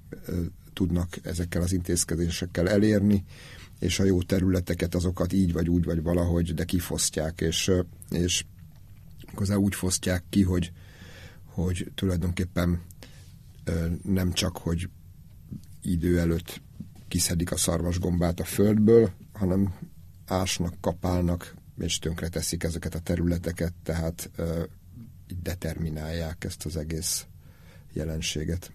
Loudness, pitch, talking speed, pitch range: -27 LUFS, 90 Hz, 105 wpm, 85-95 Hz